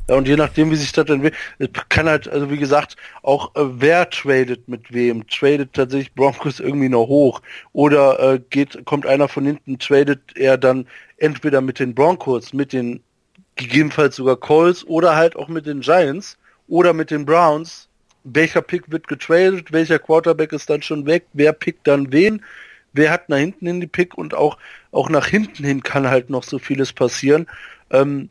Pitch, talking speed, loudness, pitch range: 145 Hz, 190 wpm, -17 LUFS, 135-160 Hz